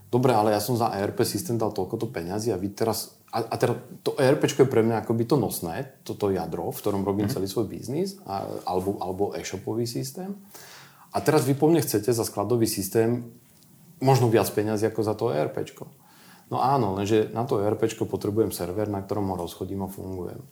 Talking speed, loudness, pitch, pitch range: 195 wpm, -26 LUFS, 110 Hz, 100-130 Hz